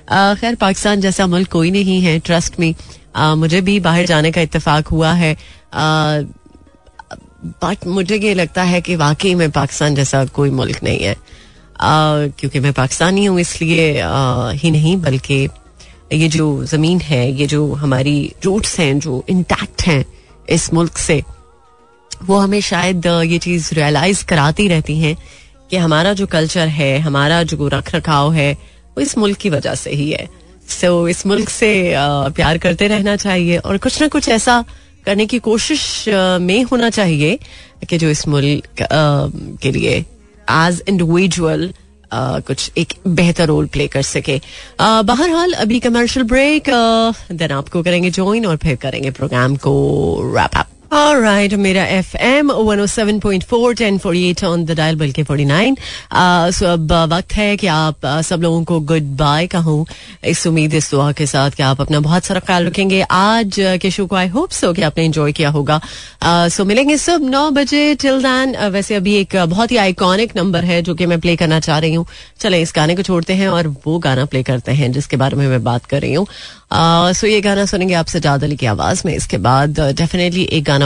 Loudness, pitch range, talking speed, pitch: -14 LUFS, 150-195 Hz, 180 wpm, 170 Hz